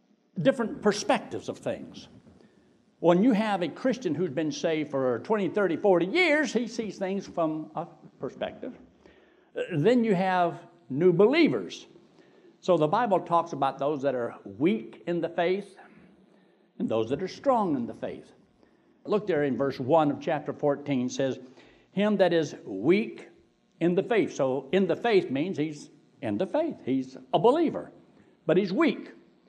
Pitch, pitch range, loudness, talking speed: 185 Hz, 155-215 Hz, -27 LUFS, 165 wpm